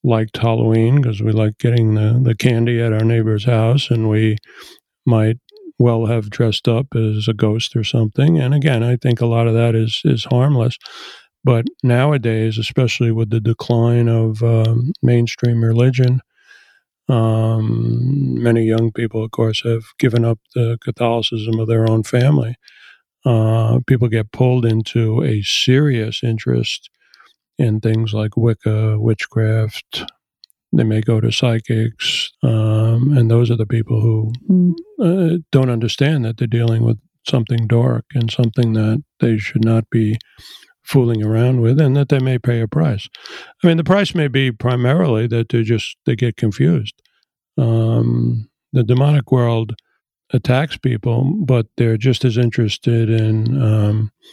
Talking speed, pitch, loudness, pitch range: 150 wpm, 115 Hz, -16 LUFS, 110-125 Hz